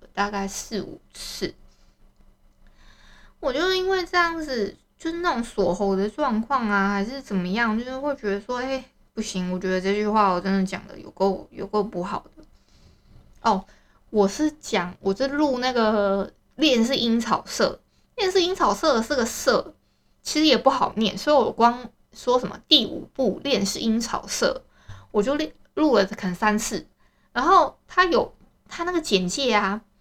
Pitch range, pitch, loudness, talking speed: 200-280 Hz, 225 Hz, -23 LUFS, 235 characters per minute